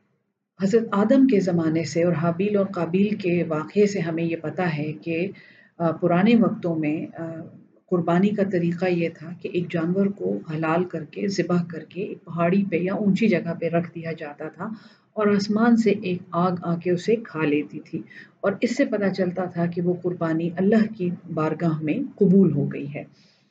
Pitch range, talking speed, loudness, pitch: 165-200 Hz, 185 wpm, -23 LUFS, 180 Hz